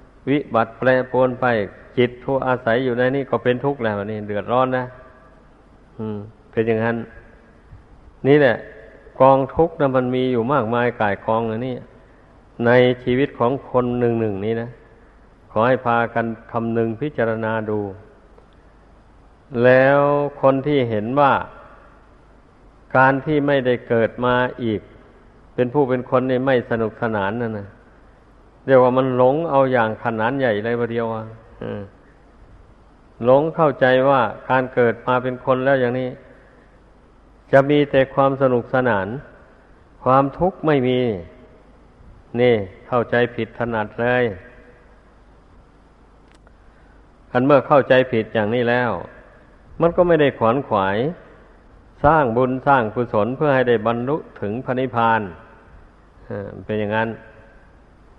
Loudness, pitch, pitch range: -19 LUFS, 120 Hz, 110-130 Hz